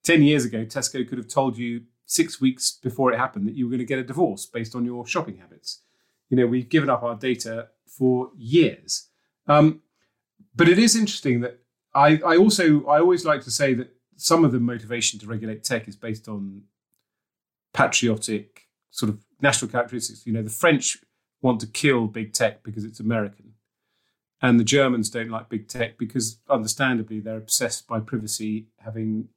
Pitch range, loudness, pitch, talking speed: 110-135 Hz, -22 LUFS, 120 Hz, 185 wpm